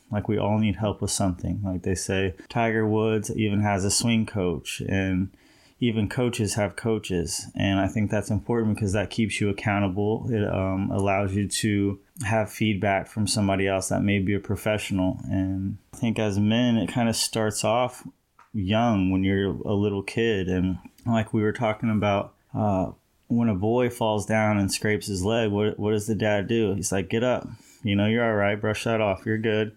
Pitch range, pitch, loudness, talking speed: 100-110 Hz, 105 Hz, -25 LUFS, 200 wpm